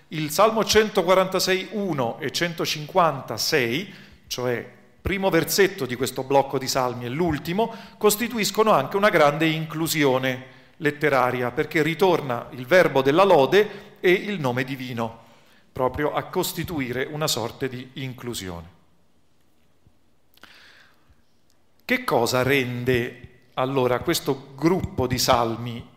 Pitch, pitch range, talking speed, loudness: 140 Hz, 125-175 Hz, 105 wpm, -22 LUFS